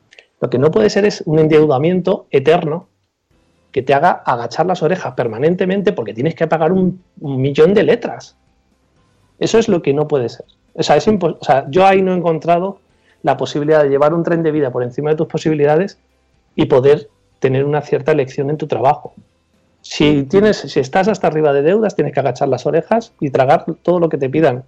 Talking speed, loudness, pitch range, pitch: 205 wpm, -15 LUFS, 135-175 Hz, 155 Hz